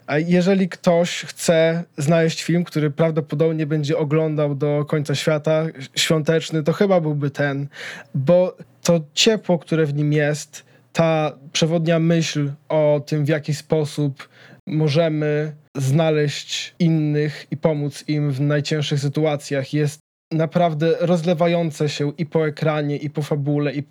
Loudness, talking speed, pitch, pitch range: -20 LUFS, 135 wpm, 155 Hz, 150-165 Hz